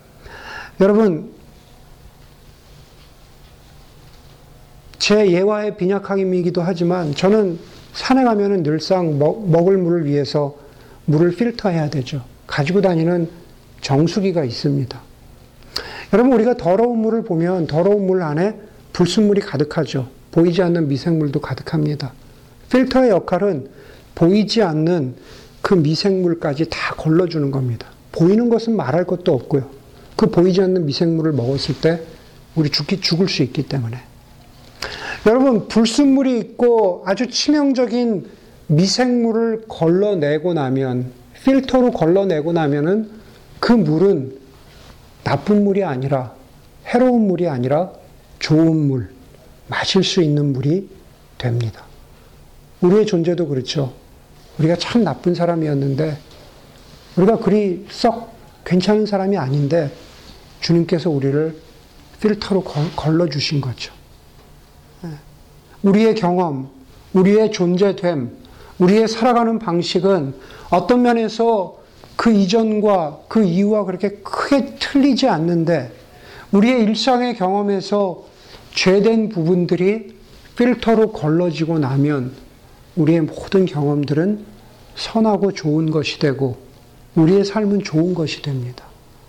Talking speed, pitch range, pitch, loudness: 250 characters per minute, 145-205 Hz, 175 Hz, -17 LUFS